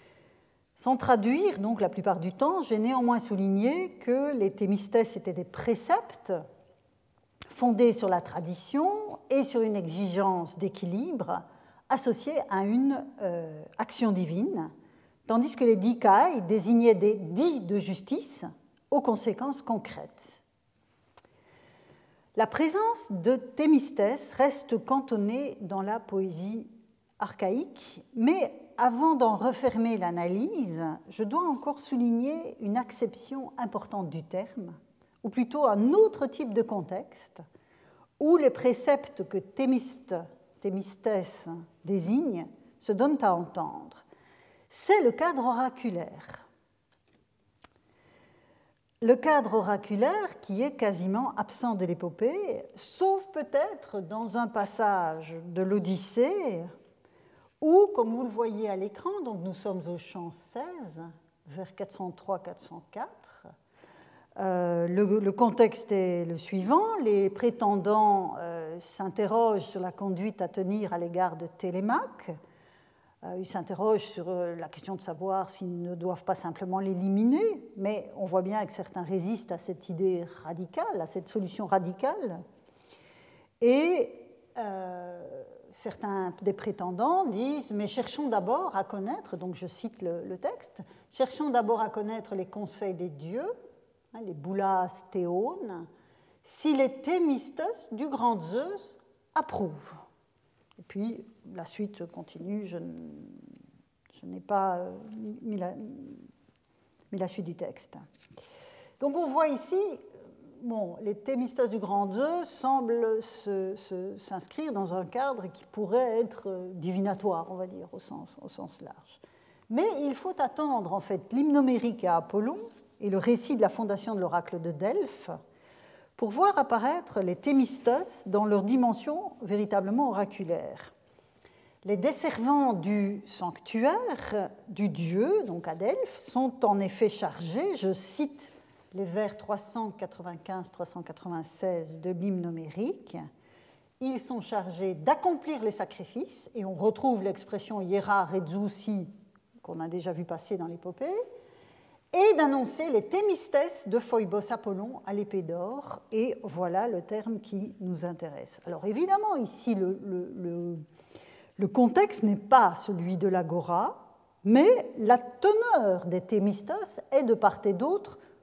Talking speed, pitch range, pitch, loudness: 125 wpm, 190-260 Hz, 210 Hz, -29 LUFS